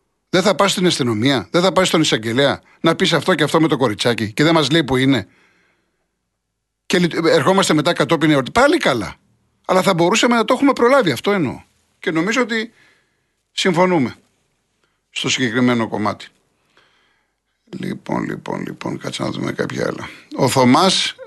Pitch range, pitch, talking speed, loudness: 140-195 Hz, 165 Hz, 160 wpm, -17 LUFS